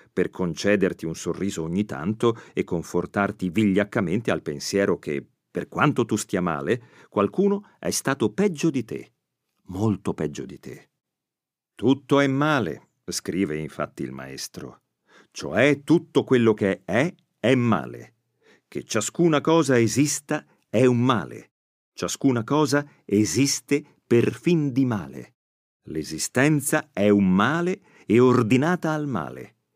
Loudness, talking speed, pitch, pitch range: -23 LUFS, 125 wpm, 125 Hz, 100-145 Hz